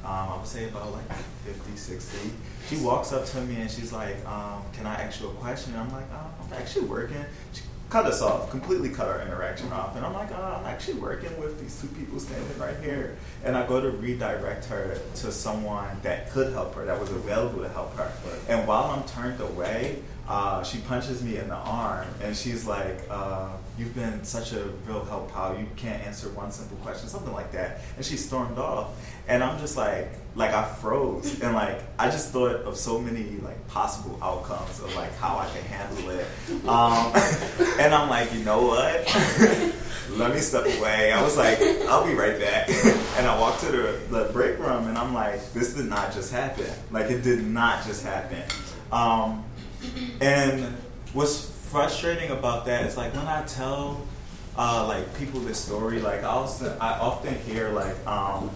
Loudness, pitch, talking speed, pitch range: -27 LUFS, 115 Hz, 200 wpm, 105-125 Hz